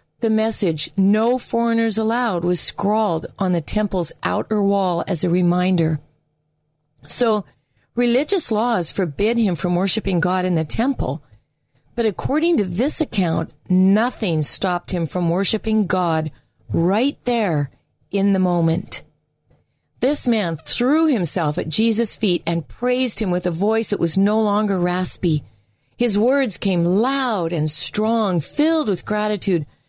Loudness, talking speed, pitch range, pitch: -19 LUFS, 140 wpm, 170-225 Hz, 190 Hz